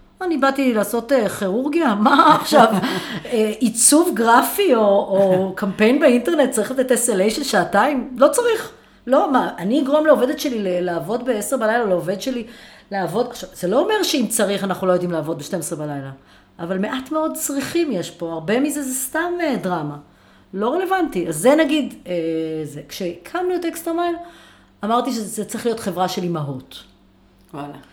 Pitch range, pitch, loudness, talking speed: 180-285 Hz, 230 Hz, -19 LUFS, 150 wpm